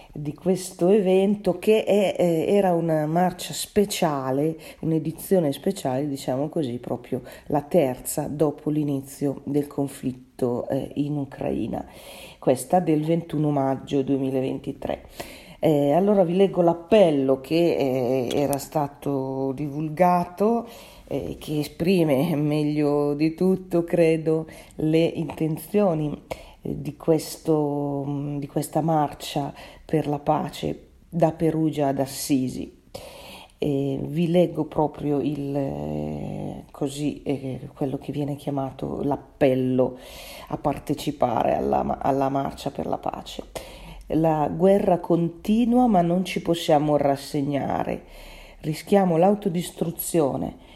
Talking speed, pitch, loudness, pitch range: 105 wpm, 150 Hz, -24 LUFS, 140-170 Hz